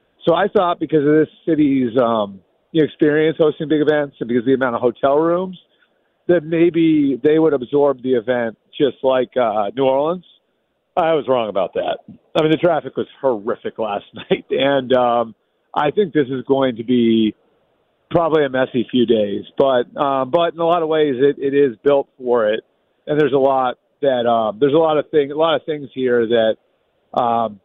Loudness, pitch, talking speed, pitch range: -17 LUFS, 140 Hz, 200 wpm, 125-155 Hz